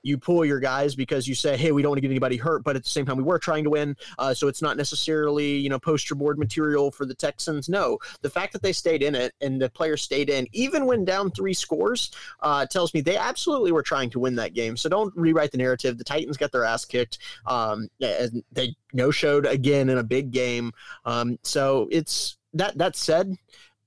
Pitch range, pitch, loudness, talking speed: 130-160 Hz, 145 Hz, -24 LUFS, 235 wpm